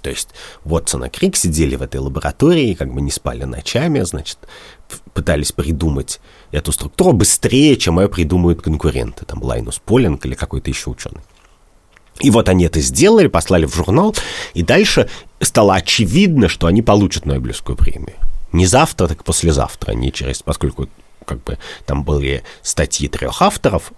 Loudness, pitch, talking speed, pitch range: -15 LUFS, 80 Hz, 160 wpm, 70-95 Hz